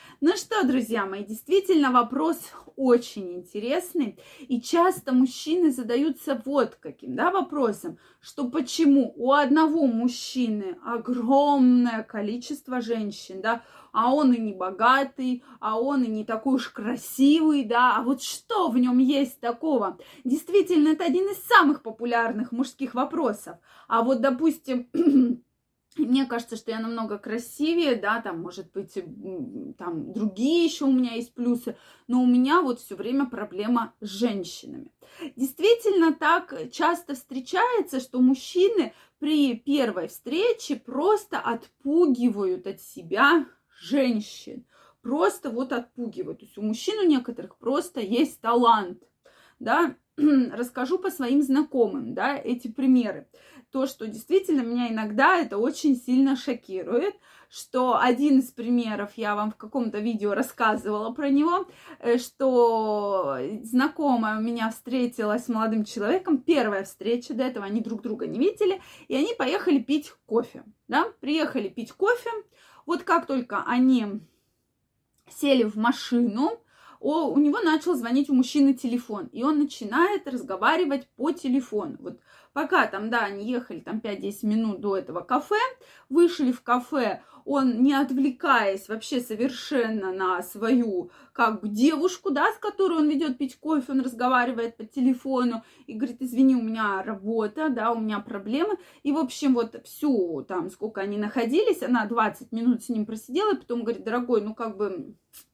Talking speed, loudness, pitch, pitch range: 145 wpm, -25 LUFS, 255 Hz, 230-295 Hz